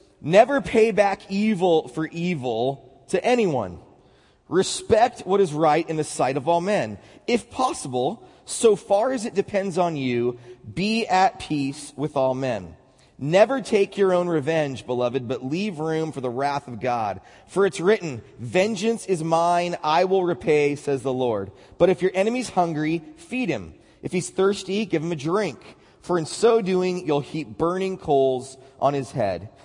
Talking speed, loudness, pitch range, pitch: 170 wpm, -23 LUFS, 135-195 Hz, 165 Hz